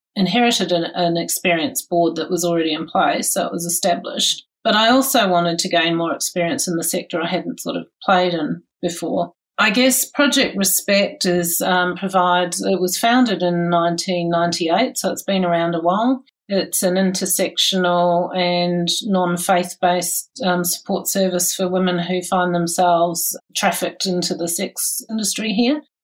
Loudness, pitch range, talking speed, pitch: -18 LUFS, 175-195 Hz, 160 wpm, 180 Hz